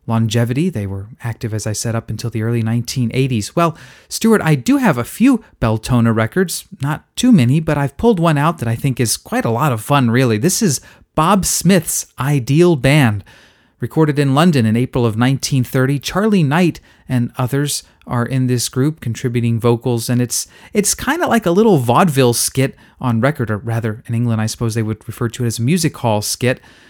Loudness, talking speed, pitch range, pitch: -16 LUFS, 205 wpm, 115-155 Hz, 130 Hz